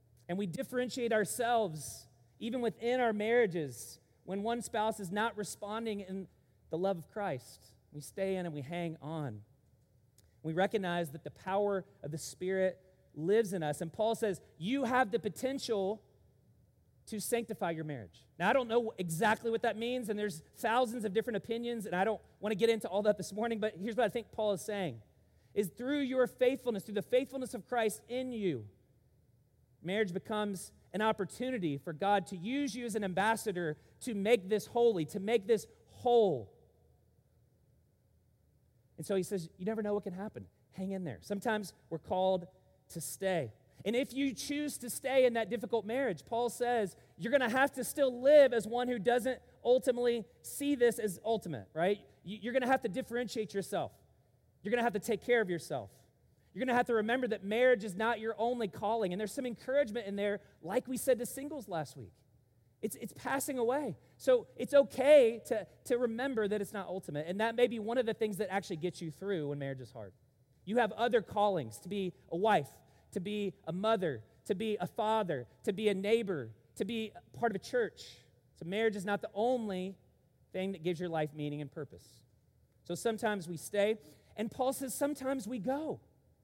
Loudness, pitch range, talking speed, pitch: -34 LUFS, 175-240 Hz, 195 wpm, 210 Hz